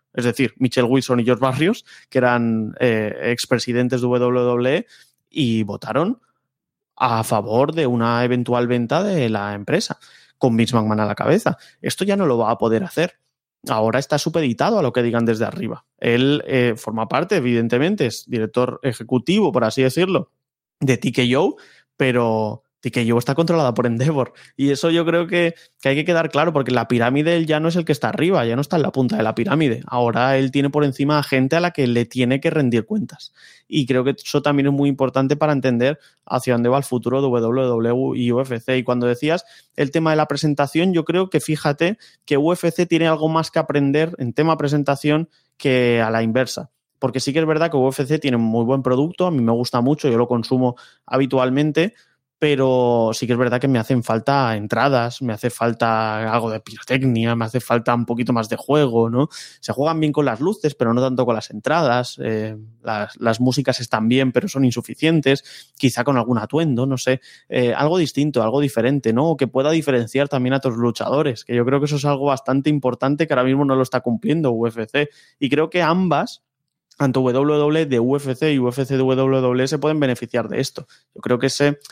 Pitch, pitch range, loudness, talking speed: 130 Hz, 120-145 Hz, -19 LUFS, 205 wpm